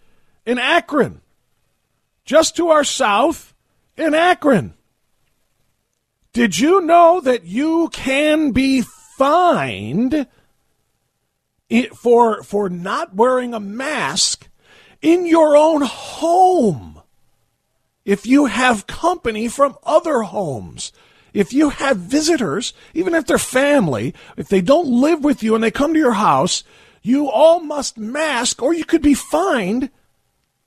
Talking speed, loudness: 120 wpm, -16 LUFS